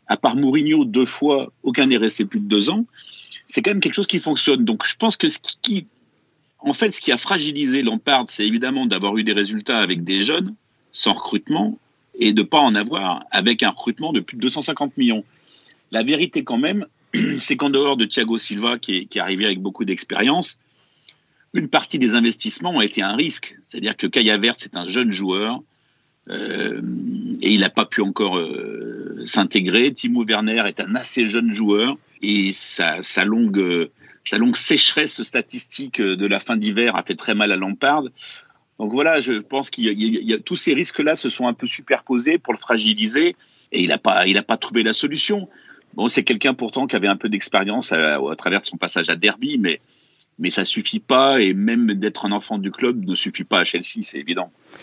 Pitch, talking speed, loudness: 140 Hz, 200 wpm, -19 LUFS